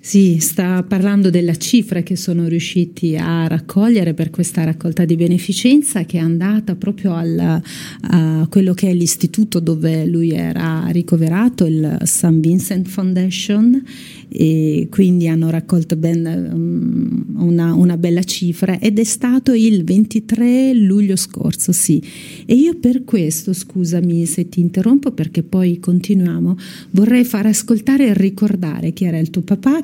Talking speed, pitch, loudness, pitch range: 145 wpm, 180 Hz, -15 LUFS, 170-205 Hz